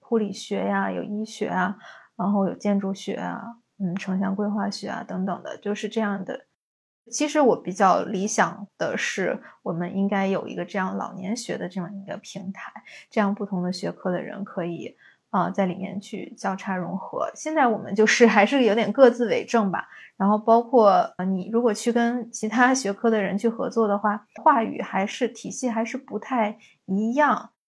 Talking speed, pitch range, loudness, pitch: 275 characters per minute, 195-230 Hz, -24 LUFS, 205 Hz